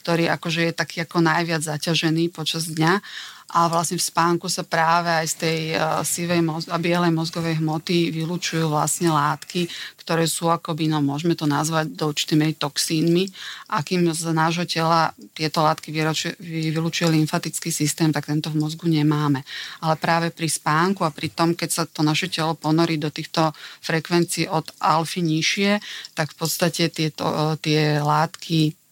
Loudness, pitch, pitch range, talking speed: -22 LUFS, 165 Hz, 155-170 Hz, 160 wpm